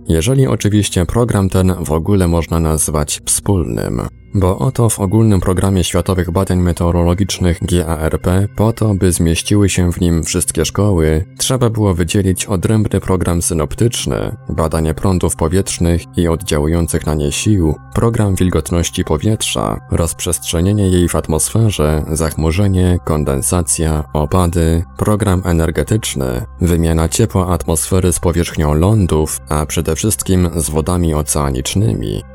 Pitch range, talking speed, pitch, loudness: 80-100 Hz, 120 wpm, 90 Hz, -15 LUFS